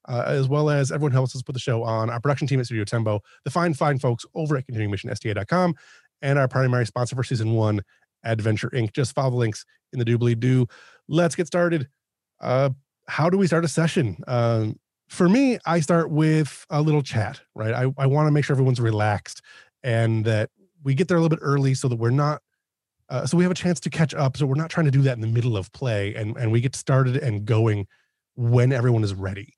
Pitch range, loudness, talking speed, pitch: 115-150 Hz, -23 LUFS, 230 wpm, 130 Hz